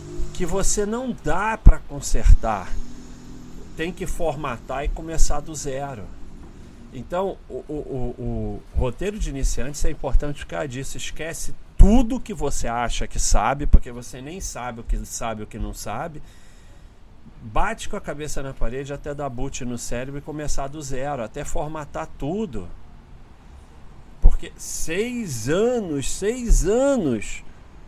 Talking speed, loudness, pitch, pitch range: 140 wpm, -26 LUFS, 135 Hz, 110-155 Hz